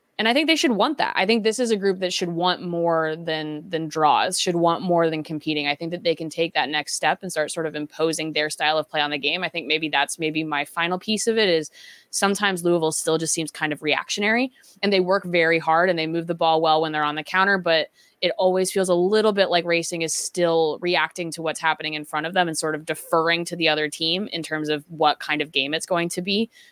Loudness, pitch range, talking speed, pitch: -22 LUFS, 155-180 Hz, 265 wpm, 165 Hz